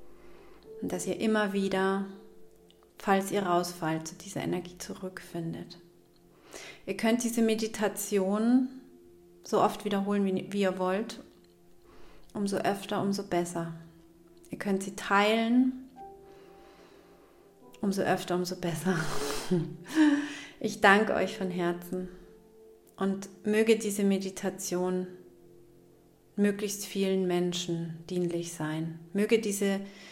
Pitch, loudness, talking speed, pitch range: 195 Hz, -30 LUFS, 100 wpm, 175-210 Hz